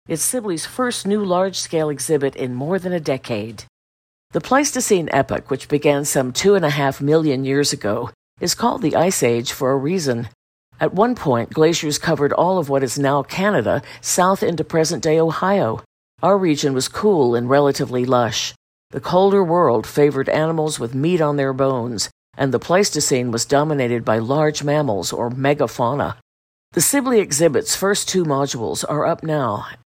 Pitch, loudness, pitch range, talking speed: 145 Hz, -18 LUFS, 130-170 Hz, 170 wpm